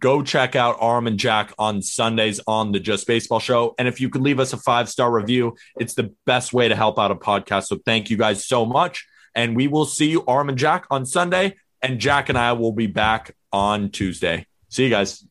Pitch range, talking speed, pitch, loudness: 110-130 Hz, 235 wpm, 120 Hz, -20 LUFS